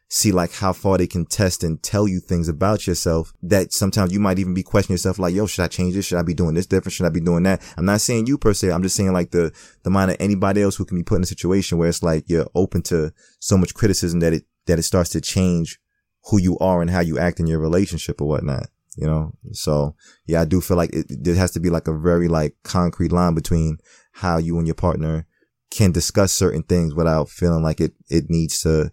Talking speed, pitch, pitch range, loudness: 260 wpm, 90 Hz, 80-95 Hz, -20 LUFS